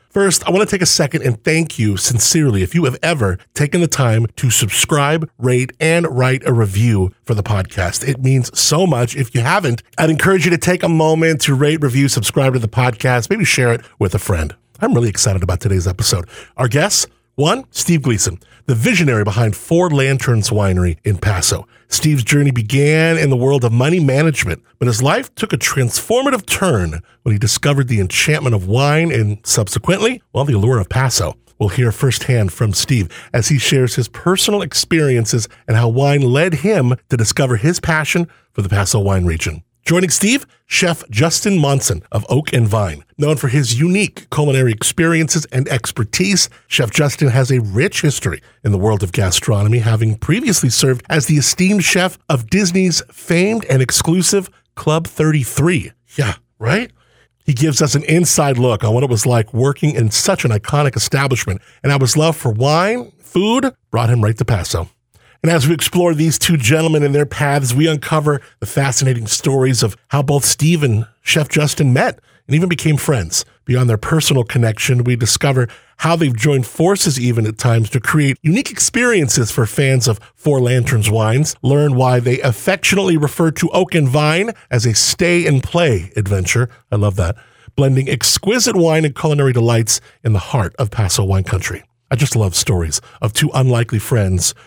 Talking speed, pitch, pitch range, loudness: 185 wpm, 130 Hz, 115-160 Hz, -15 LUFS